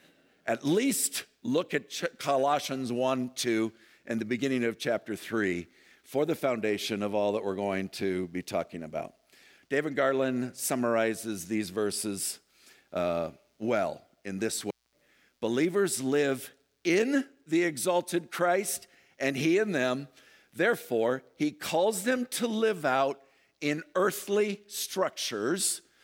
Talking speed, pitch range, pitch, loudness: 125 wpm, 110-175 Hz, 135 Hz, -30 LUFS